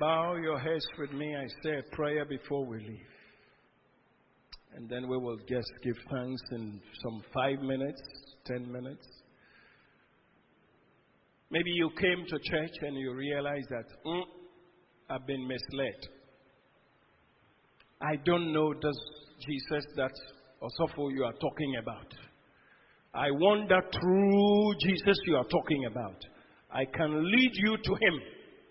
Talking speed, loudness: 130 wpm, -32 LUFS